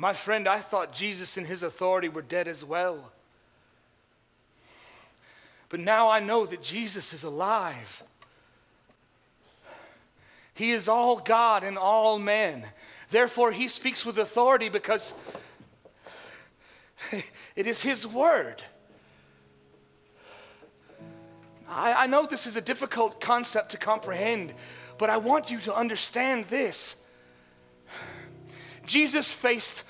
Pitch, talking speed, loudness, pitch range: 220 Hz, 110 wpm, -26 LUFS, 185-240 Hz